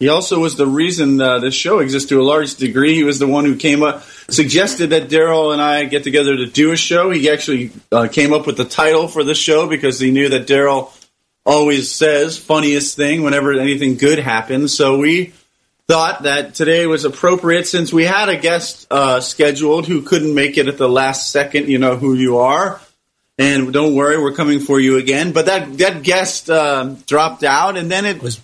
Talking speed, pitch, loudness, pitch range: 215 wpm, 145 Hz, -14 LUFS, 135-160 Hz